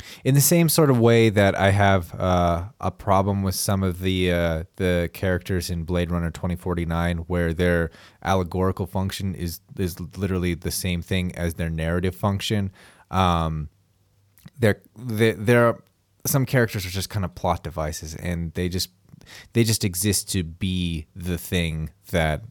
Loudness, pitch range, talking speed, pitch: -23 LUFS, 85-100 Hz, 165 wpm, 95 Hz